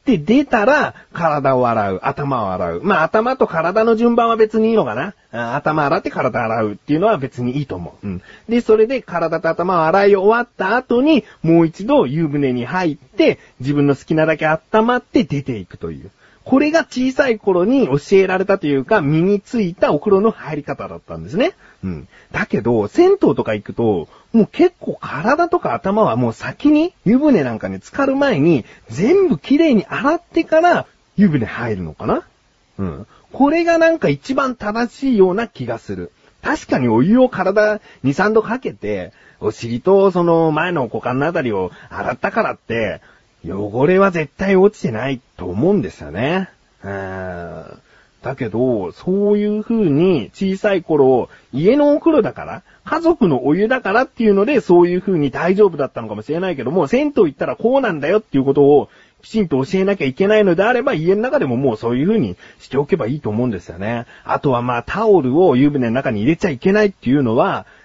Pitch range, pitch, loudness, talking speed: 135-230 Hz, 190 Hz, -16 LUFS, 360 characters per minute